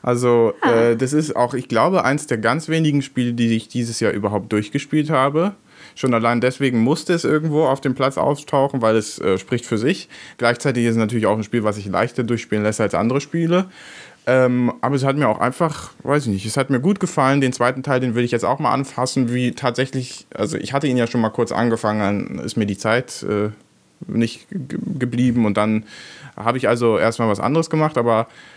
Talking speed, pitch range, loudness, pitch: 220 wpm, 115-140 Hz, -19 LUFS, 125 Hz